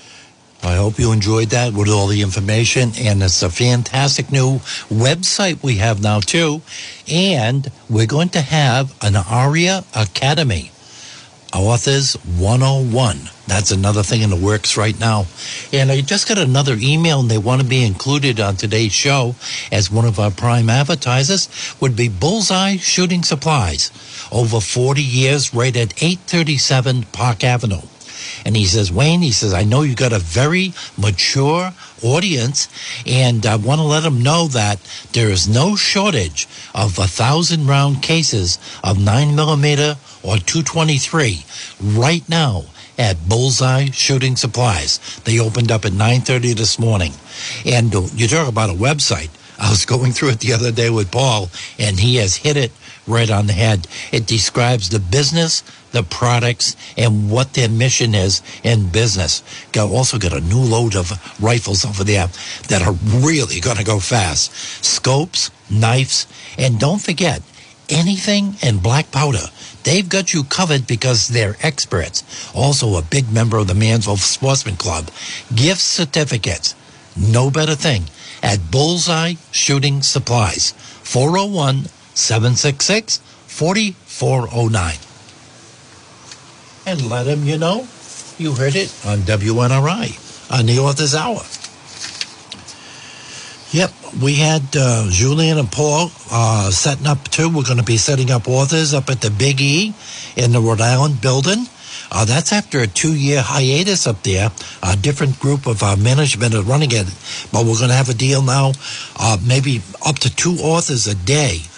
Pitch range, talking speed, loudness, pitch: 110-145 Hz, 155 wpm, -16 LUFS, 125 Hz